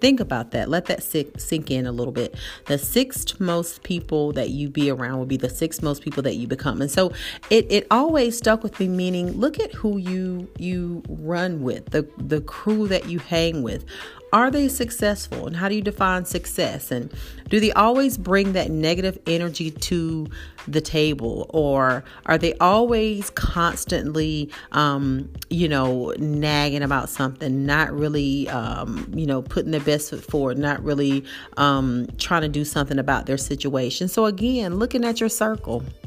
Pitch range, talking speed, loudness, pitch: 140-190 Hz, 180 wpm, -22 LUFS, 160 Hz